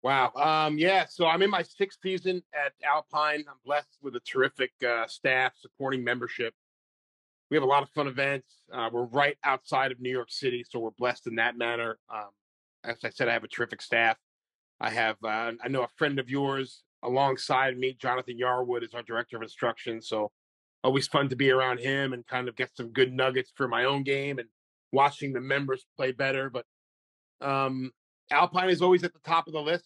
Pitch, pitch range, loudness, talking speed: 130 Hz, 120-145 Hz, -28 LUFS, 205 wpm